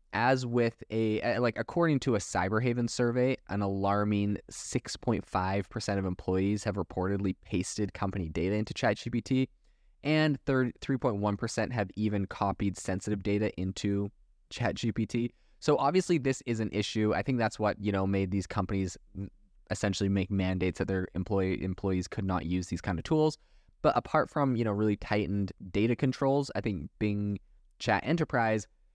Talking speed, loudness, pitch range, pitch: 150 wpm, -31 LUFS, 95-120 Hz, 105 Hz